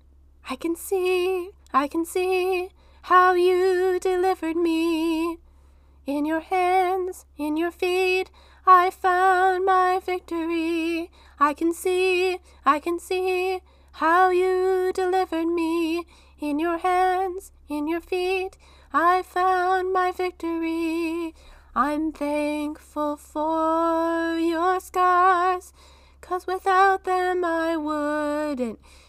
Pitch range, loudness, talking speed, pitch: 325-370 Hz, -23 LUFS, 105 wpm, 360 Hz